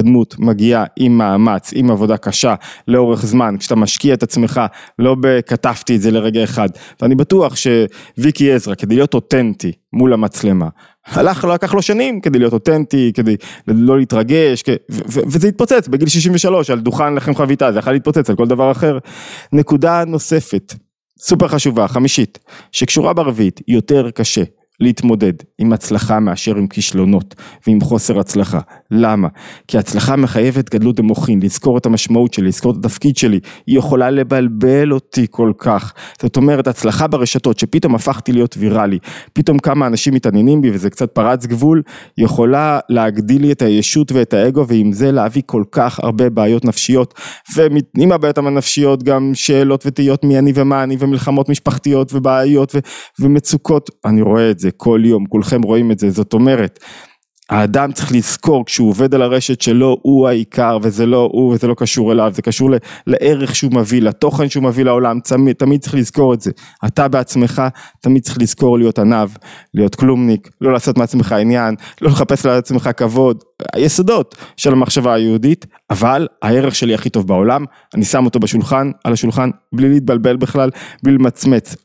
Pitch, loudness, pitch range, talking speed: 125 Hz, -13 LUFS, 115-140 Hz, 165 wpm